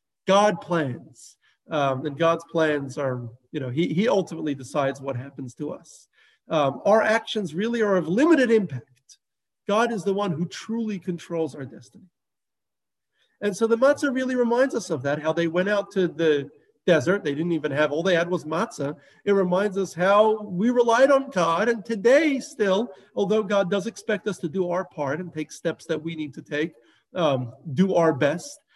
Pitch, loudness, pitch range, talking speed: 180 Hz, -24 LUFS, 150-210 Hz, 190 wpm